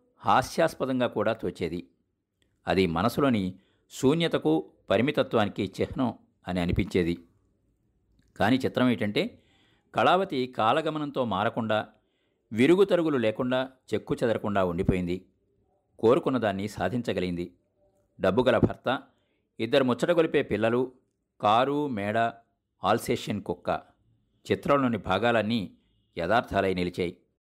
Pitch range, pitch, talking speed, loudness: 95-130 Hz, 110 Hz, 85 wpm, -27 LUFS